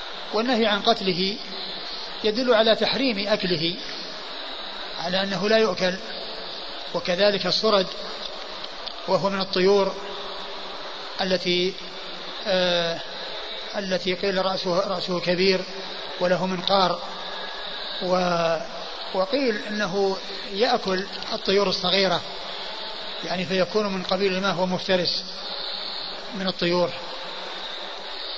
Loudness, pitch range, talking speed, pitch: -24 LUFS, 180-205 Hz, 80 wpm, 190 Hz